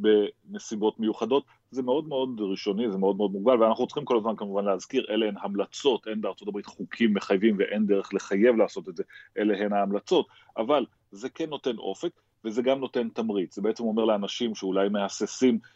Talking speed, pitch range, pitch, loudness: 185 wpm, 100-125 Hz, 110 Hz, -27 LUFS